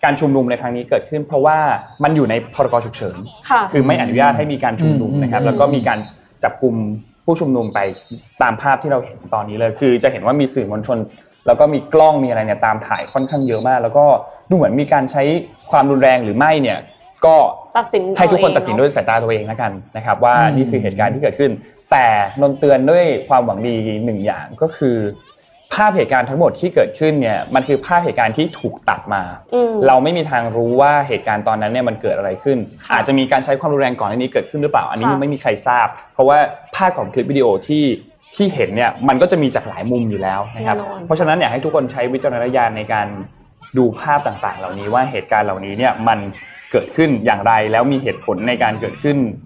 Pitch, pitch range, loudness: 130 Hz, 115-145 Hz, -16 LUFS